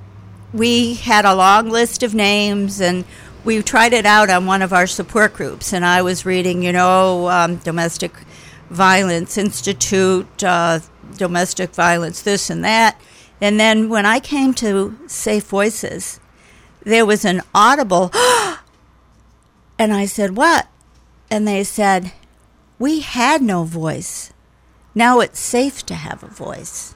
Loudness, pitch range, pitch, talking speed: -15 LUFS, 180-225 Hz, 200 Hz, 145 wpm